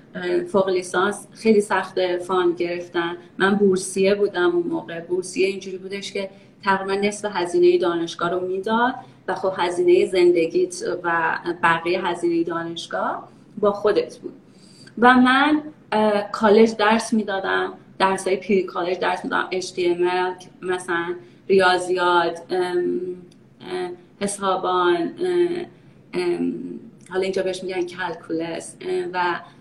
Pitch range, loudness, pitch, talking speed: 175-205 Hz, -21 LUFS, 185 Hz, 105 wpm